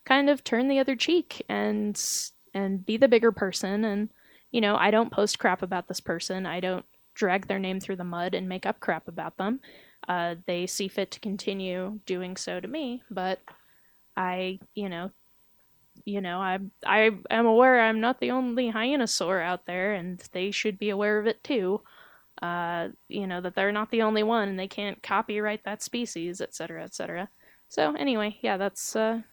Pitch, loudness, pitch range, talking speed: 200 Hz, -28 LUFS, 185-225 Hz, 195 wpm